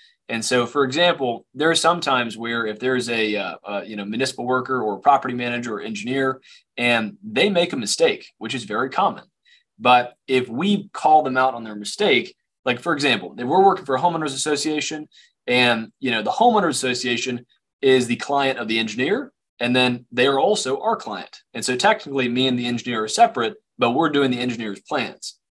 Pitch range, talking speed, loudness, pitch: 120-155 Hz, 200 wpm, -21 LUFS, 130 Hz